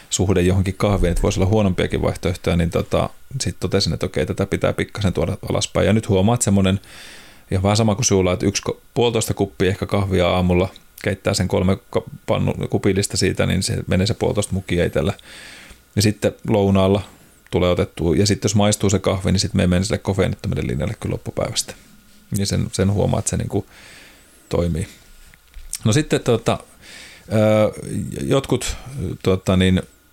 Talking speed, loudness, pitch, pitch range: 165 wpm, -20 LUFS, 100 Hz, 95-110 Hz